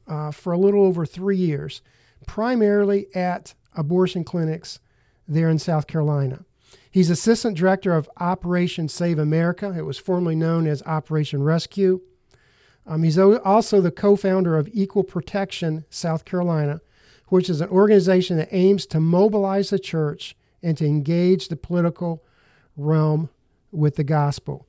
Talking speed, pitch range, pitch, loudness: 145 wpm, 150-185 Hz, 165 Hz, -21 LUFS